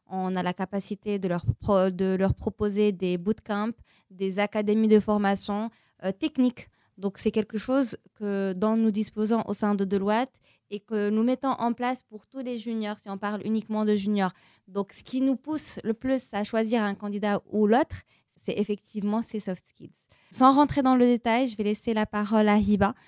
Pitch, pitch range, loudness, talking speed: 210 Hz, 200-230 Hz, -26 LUFS, 200 wpm